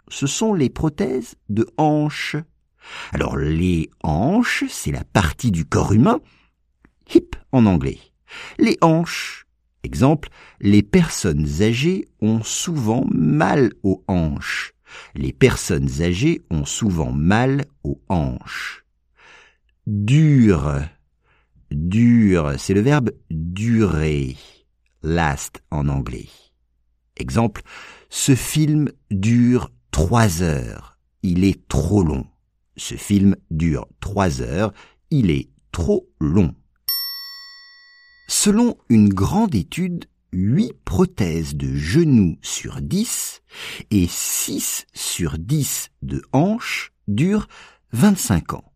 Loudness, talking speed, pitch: -19 LUFS, 105 wpm, 105 Hz